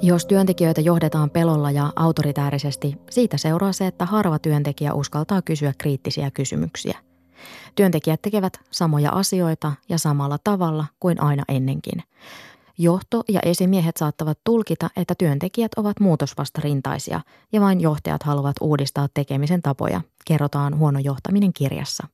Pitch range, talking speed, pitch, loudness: 145-180 Hz, 125 wpm, 155 Hz, -21 LUFS